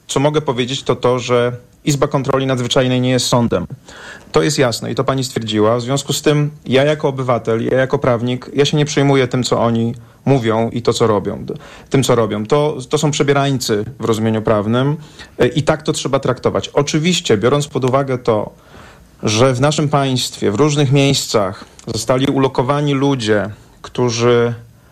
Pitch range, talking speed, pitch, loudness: 120-145 Hz, 175 wpm, 130 Hz, -16 LUFS